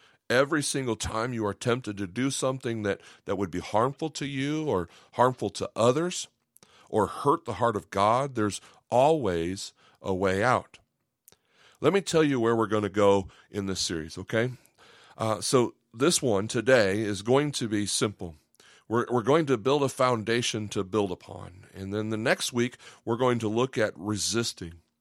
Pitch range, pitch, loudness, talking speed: 100-125 Hz, 110 Hz, -27 LUFS, 180 wpm